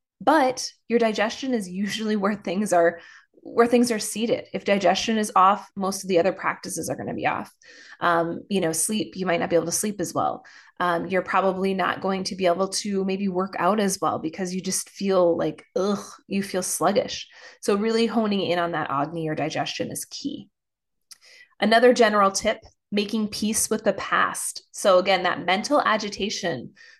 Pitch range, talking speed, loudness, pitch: 180-220 Hz, 190 wpm, -23 LUFS, 195 Hz